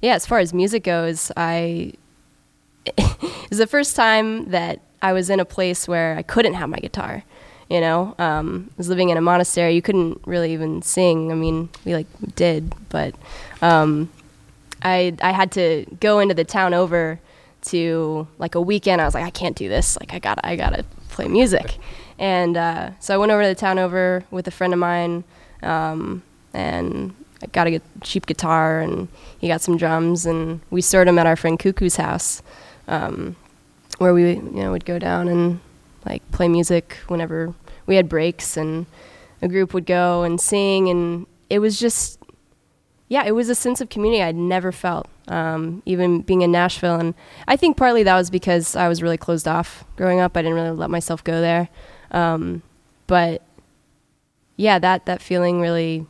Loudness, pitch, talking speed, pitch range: -20 LUFS, 175 Hz, 185 wpm, 165-185 Hz